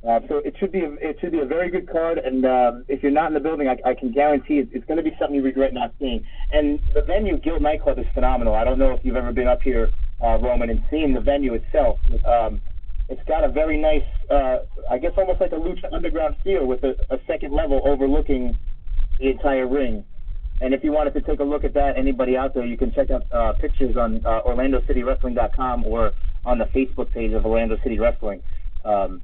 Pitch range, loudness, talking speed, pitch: 120-145 Hz, -22 LUFS, 235 wpm, 130 Hz